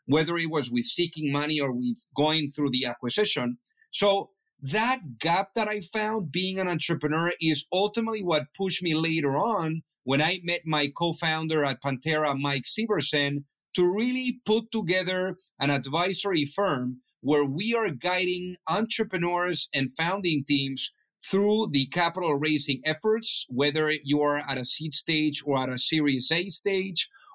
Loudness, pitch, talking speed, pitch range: -26 LUFS, 160 Hz, 155 wpm, 145-190 Hz